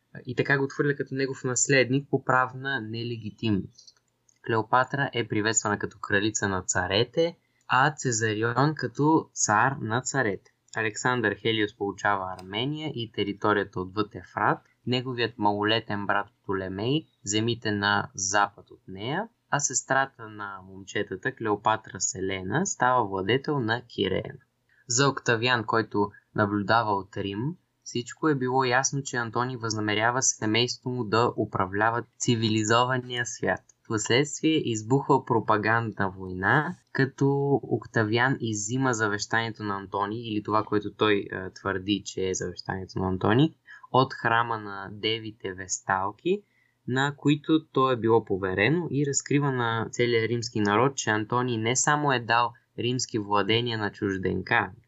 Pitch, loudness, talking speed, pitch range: 115 Hz, -26 LUFS, 130 wpm, 105-130 Hz